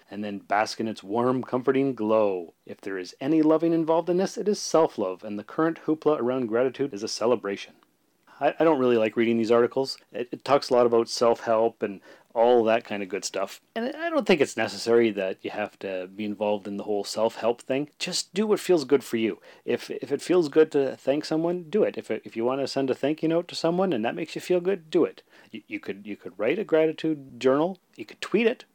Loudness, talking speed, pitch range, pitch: -25 LUFS, 250 wpm, 115-165 Hz, 135 Hz